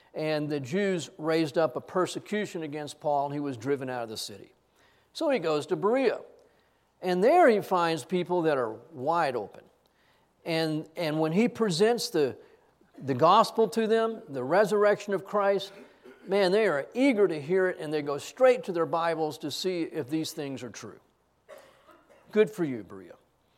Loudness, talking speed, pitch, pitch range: -27 LUFS, 180 wpm, 170 Hz, 150-205 Hz